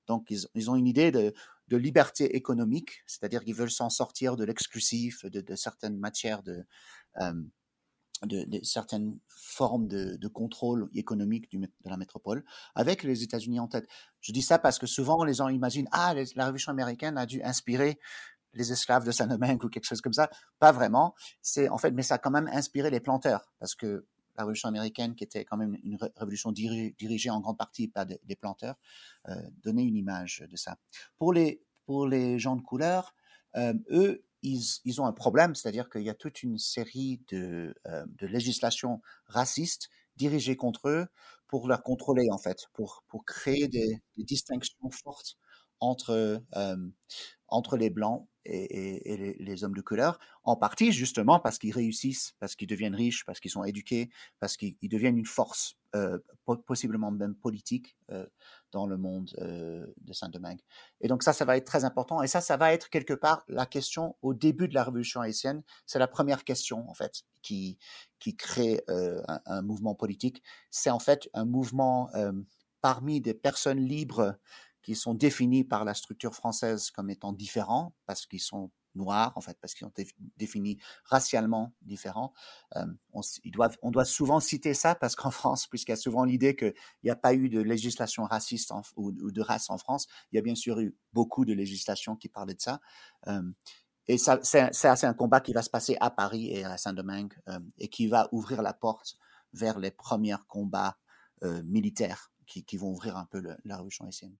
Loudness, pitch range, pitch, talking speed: -30 LUFS, 105-130 Hz, 120 Hz, 200 wpm